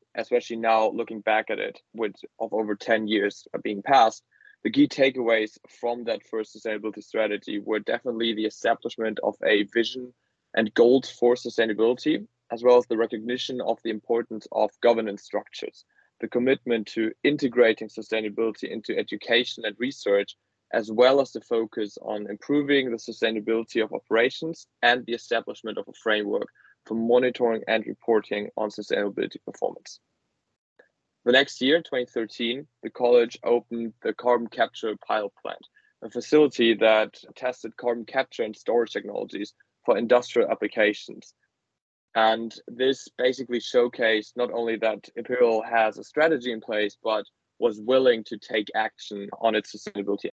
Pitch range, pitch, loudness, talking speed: 110-125 Hz, 115 Hz, -25 LUFS, 145 wpm